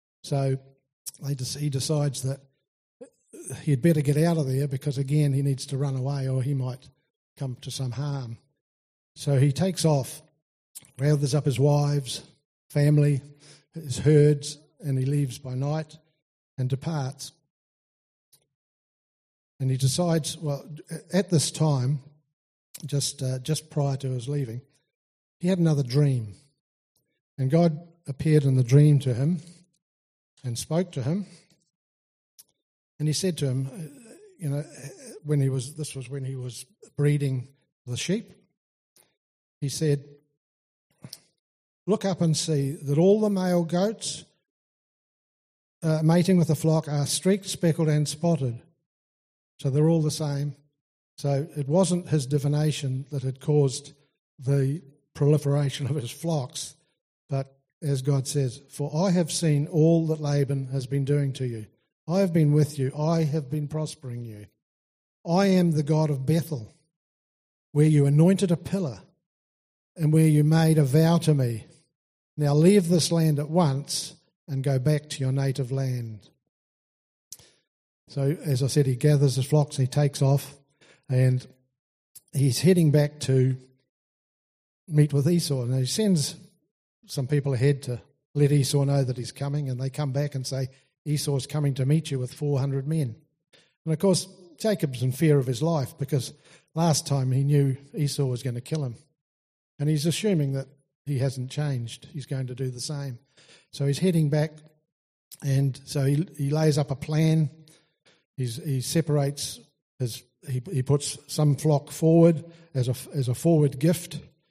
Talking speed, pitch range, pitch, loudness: 155 wpm, 135-155 Hz, 145 Hz, -25 LUFS